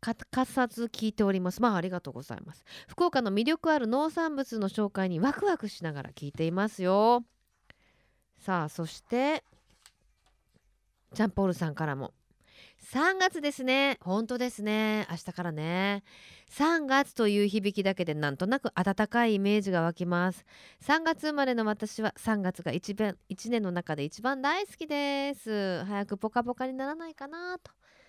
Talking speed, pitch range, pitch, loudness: 300 characters per minute, 185-265 Hz, 215 Hz, -30 LUFS